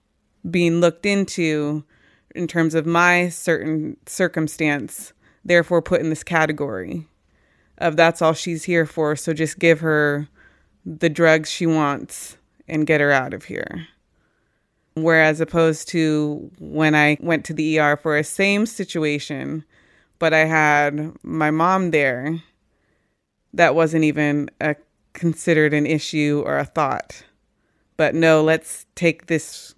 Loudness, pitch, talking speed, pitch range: -19 LUFS, 155 Hz, 135 wpm, 150-165 Hz